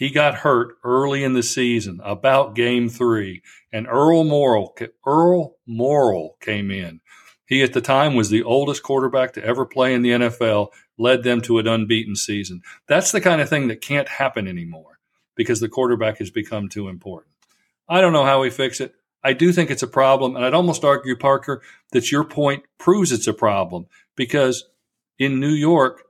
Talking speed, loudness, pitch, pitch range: 190 wpm, -19 LUFS, 130 Hz, 115-140 Hz